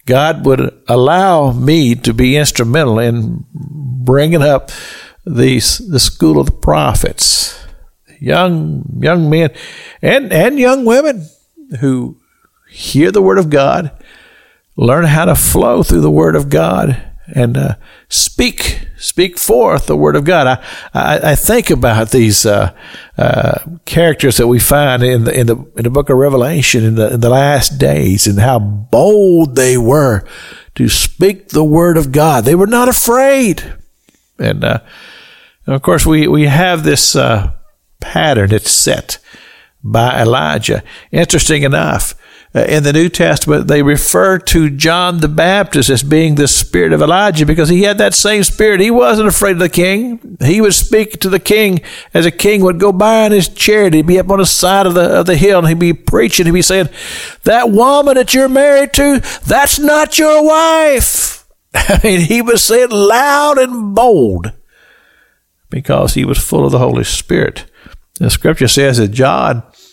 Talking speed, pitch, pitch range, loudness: 170 wpm, 165 Hz, 135-205 Hz, -10 LUFS